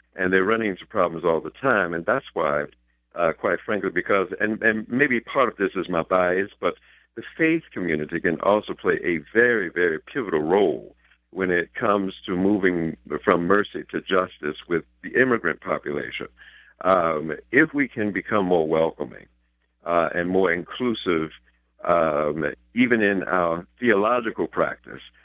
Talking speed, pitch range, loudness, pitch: 155 wpm, 80-105 Hz, -23 LUFS, 90 Hz